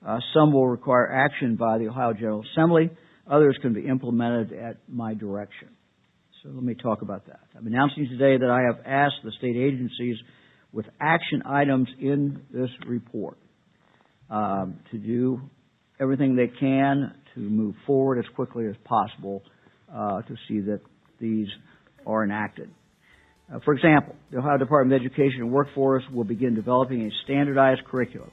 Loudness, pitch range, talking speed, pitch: -24 LUFS, 110-135 Hz, 160 wpm, 125 Hz